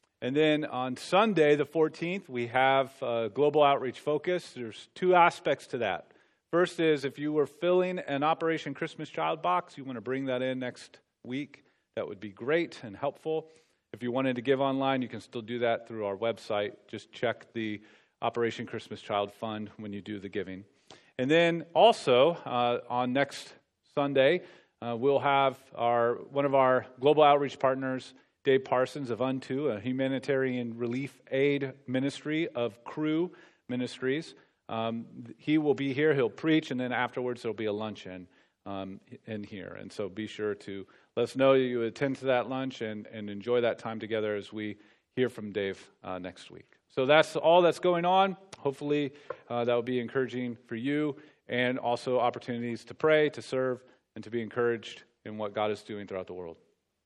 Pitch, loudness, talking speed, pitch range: 130 Hz, -29 LUFS, 185 wpm, 115-145 Hz